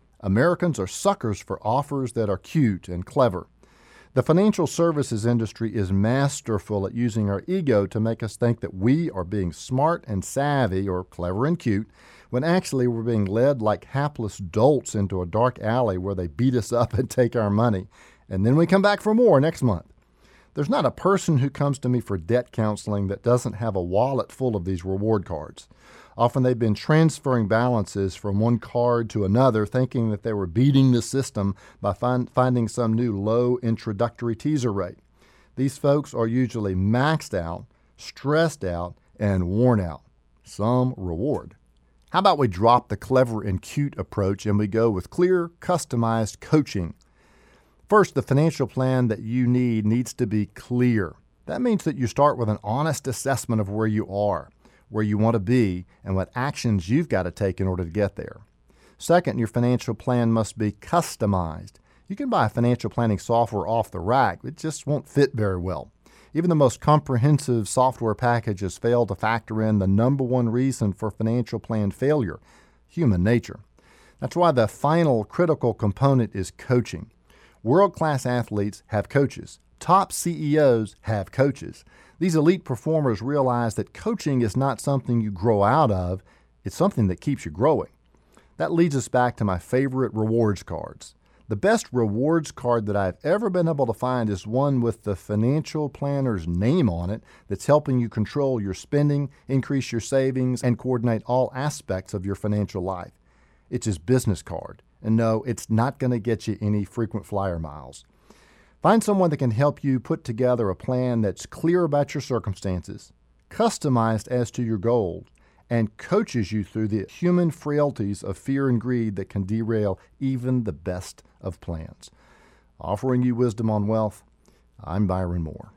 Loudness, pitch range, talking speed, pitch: -23 LUFS, 100-130 Hz, 175 wpm, 115 Hz